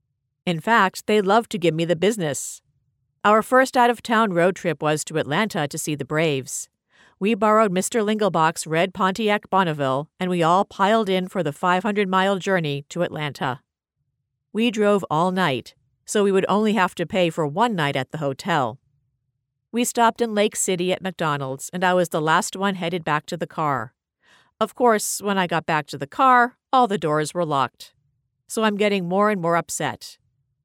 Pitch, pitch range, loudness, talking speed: 180 Hz, 145-205 Hz, -21 LUFS, 190 wpm